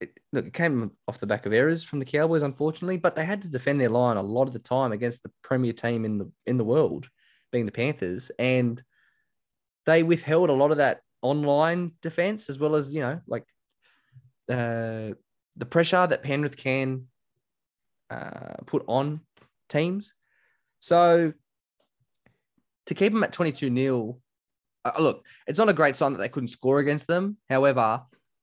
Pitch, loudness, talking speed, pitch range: 140 Hz, -25 LUFS, 170 wpm, 125-165 Hz